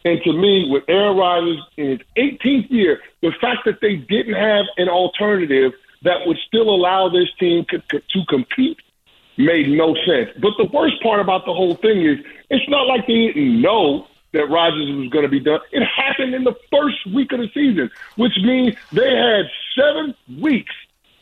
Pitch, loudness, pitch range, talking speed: 210 Hz, -17 LUFS, 175-260 Hz, 190 wpm